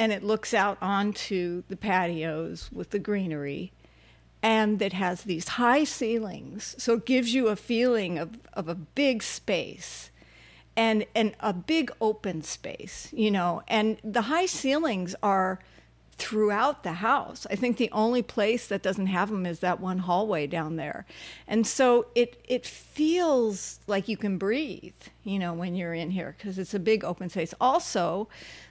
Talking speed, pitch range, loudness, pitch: 170 wpm, 185-230 Hz, -28 LUFS, 210 Hz